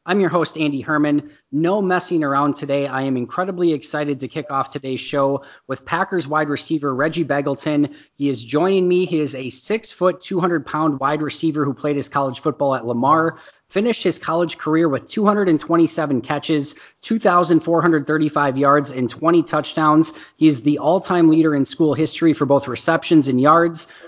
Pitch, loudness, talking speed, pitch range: 155 Hz, -19 LUFS, 175 wpm, 140-170 Hz